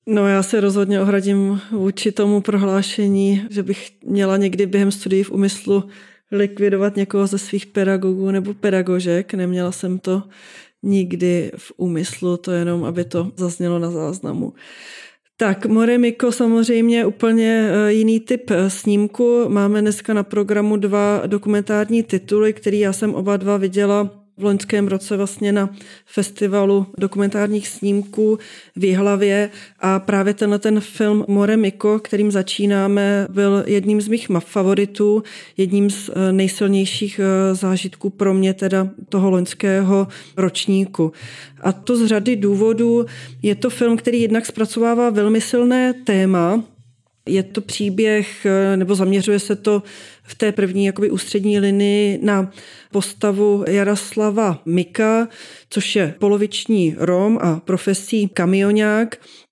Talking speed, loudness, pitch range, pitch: 130 wpm, -18 LUFS, 195-210 Hz, 200 Hz